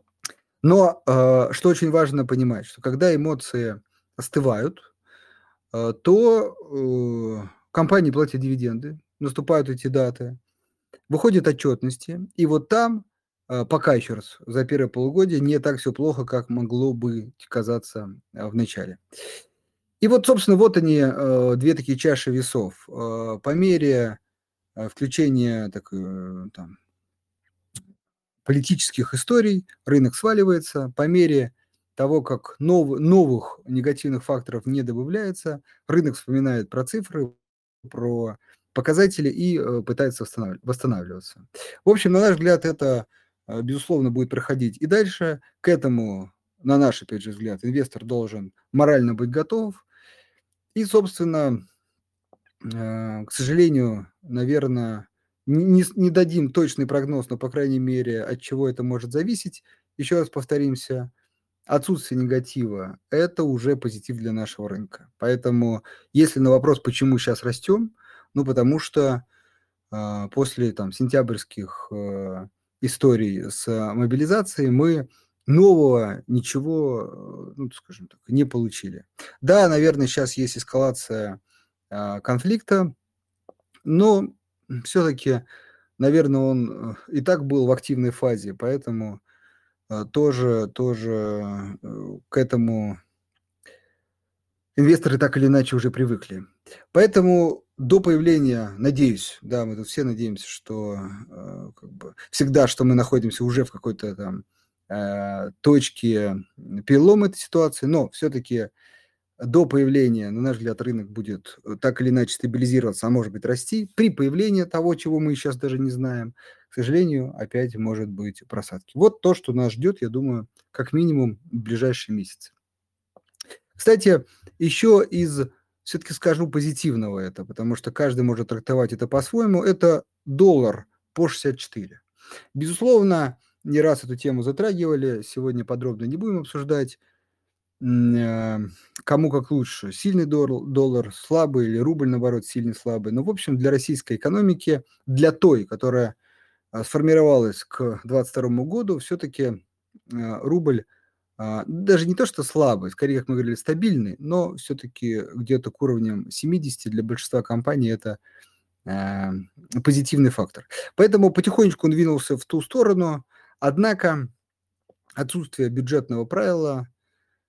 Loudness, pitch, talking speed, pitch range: -22 LUFS, 130 Hz, 120 wpm, 115-155 Hz